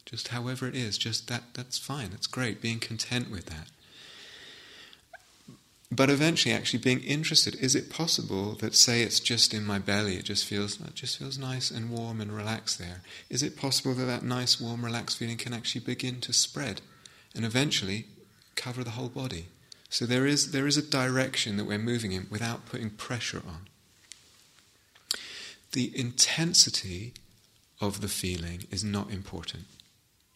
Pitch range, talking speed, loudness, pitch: 105-130 Hz, 165 wpm, -28 LUFS, 115 Hz